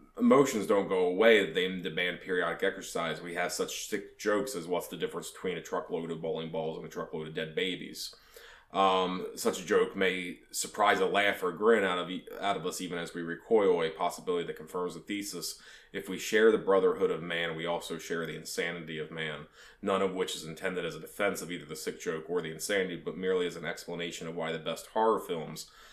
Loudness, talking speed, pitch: -31 LUFS, 220 wpm, 95 Hz